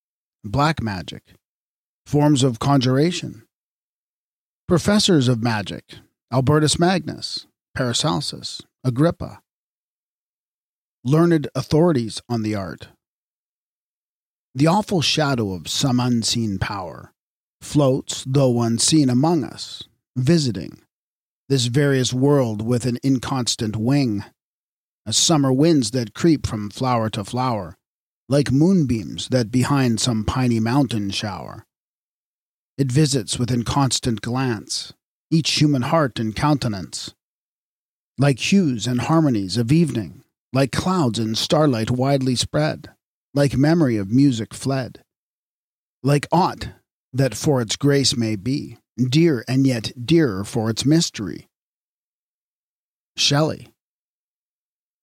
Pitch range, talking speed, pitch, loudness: 115-145 Hz, 105 wpm, 130 Hz, -20 LUFS